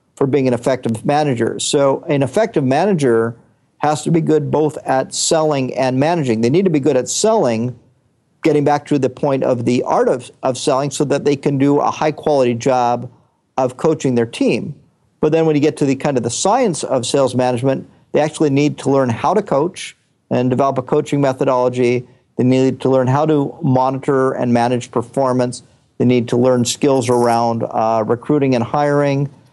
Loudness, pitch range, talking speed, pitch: -16 LUFS, 125-145 Hz, 195 wpm, 135 Hz